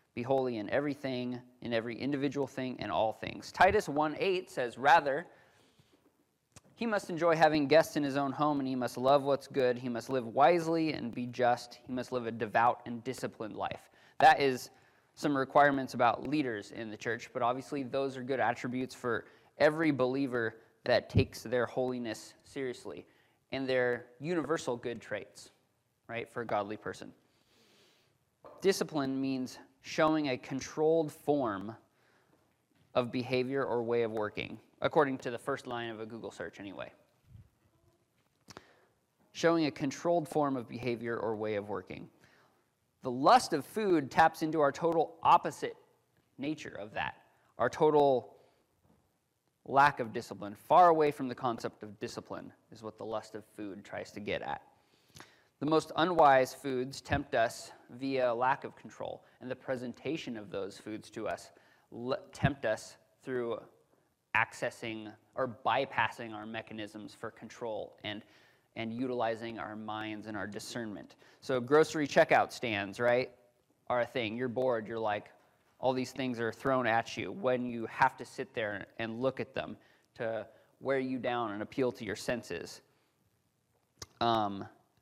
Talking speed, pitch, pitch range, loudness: 155 wpm, 125 Hz, 115-145 Hz, -32 LUFS